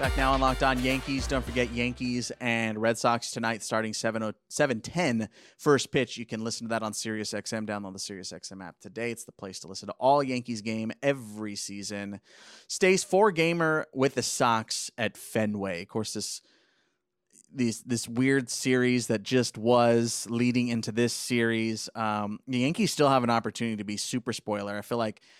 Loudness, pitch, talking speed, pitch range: -28 LUFS, 115 Hz, 185 wpm, 110-125 Hz